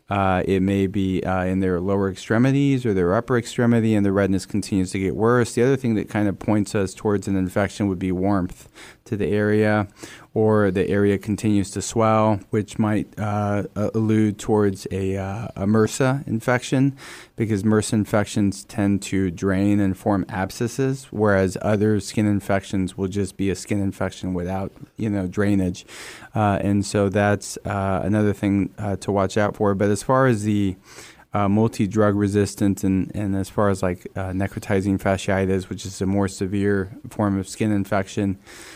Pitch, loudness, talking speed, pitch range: 100 Hz, -22 LUFS, 175 wpm, 95-110 Hz